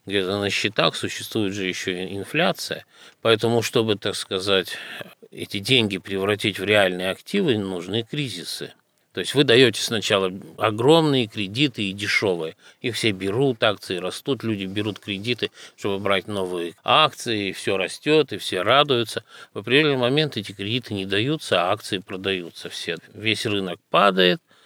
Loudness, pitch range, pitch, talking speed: -22 LUFS, 95-115 Hz, 100 Hz, 150 wpm